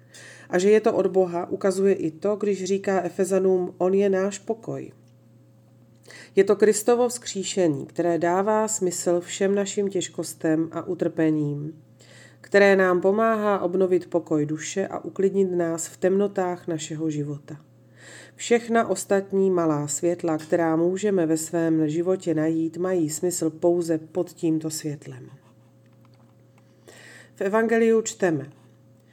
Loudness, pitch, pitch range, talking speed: -23 LUFS, 175 Hz, 160-195 Hz, 125 wpm